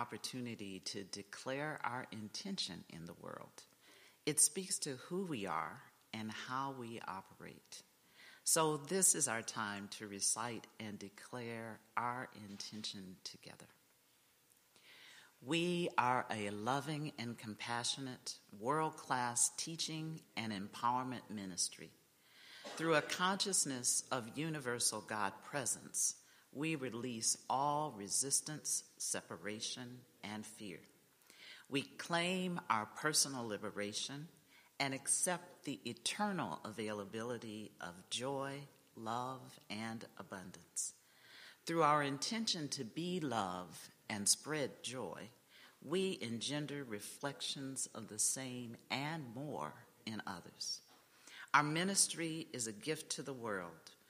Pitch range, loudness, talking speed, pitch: 110-150 Hz, -39 LUFS, 110 wpm, 125 Hz